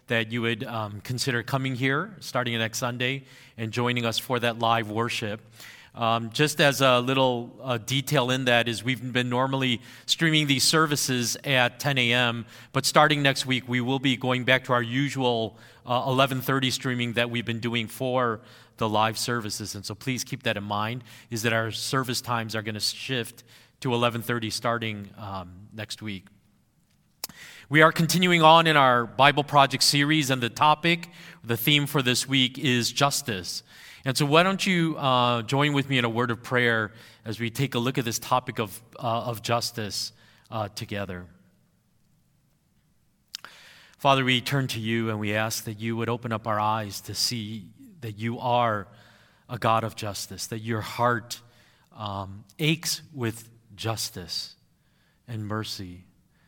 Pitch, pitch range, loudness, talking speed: 120 Hz, 110-130 Hz, -25 LUFS, 170 wpm